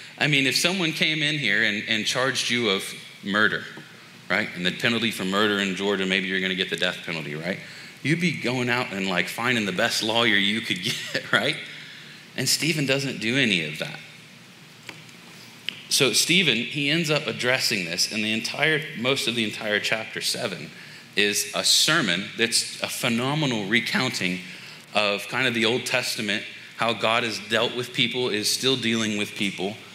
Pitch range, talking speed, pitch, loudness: 105-130 Hz, 180 wpm, 115 Hz, -23 LUFS